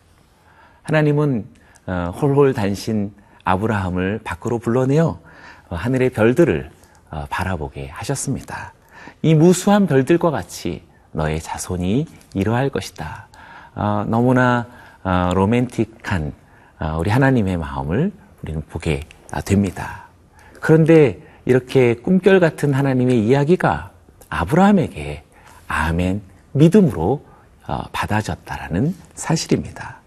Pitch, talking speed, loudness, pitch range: 110 Hz, 240 characters per minute, -19 LUFS, 90-135 Hz